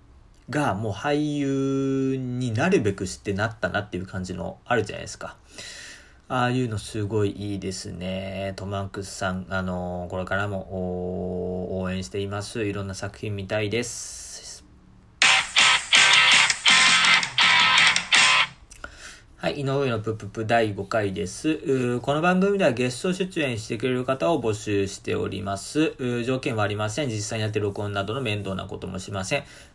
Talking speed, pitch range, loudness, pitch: 295 characters per minute, 95-125 Hz, -23 LUFS, 105 Hz